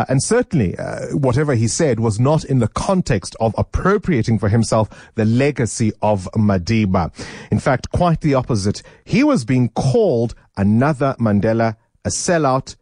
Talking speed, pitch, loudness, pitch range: 150 wpm, 115 Hz, -18 LUFS, 110-140 Hz